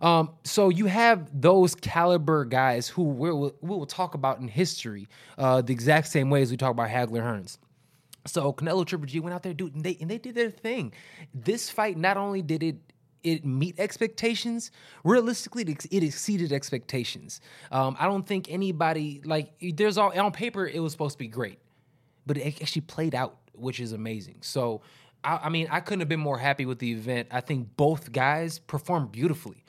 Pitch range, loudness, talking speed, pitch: 135-185 Hz, -27 LUFS, 200 wpm, 155 Hz